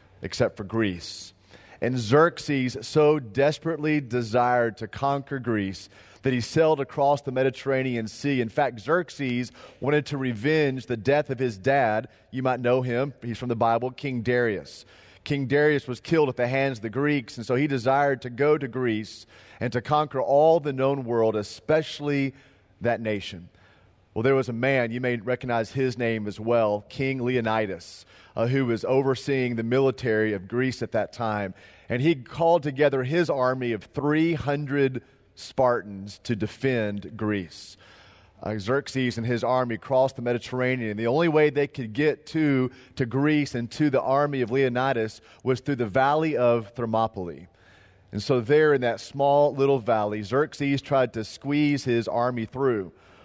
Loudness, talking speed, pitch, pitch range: -25 LUFS, 165 wpm, 125 Hz, 115-140 Hz